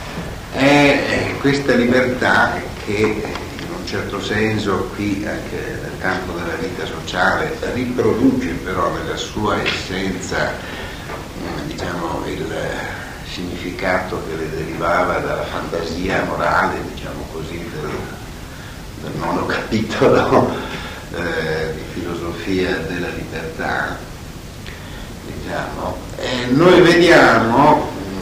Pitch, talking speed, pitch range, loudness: 95 Hz, 95 wpm, 85-120 Hz, -18 LUFS